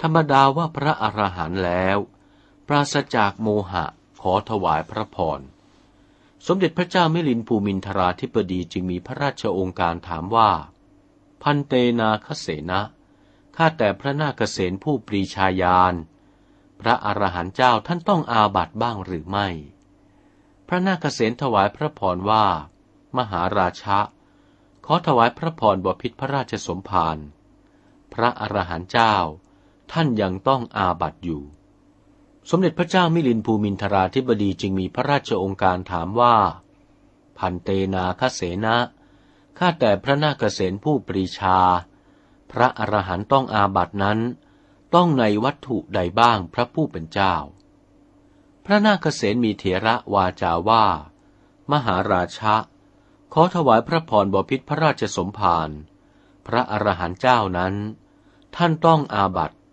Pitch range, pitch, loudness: 95-130 Hz, 105 Hz, -21 LUFS